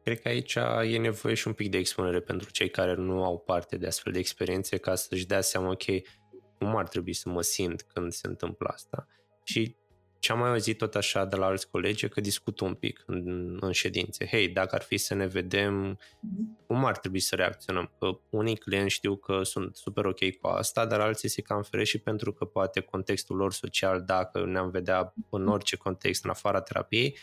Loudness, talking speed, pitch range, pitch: -30 LUFS, 210 wpm, 95-105 Hz, 95 Hz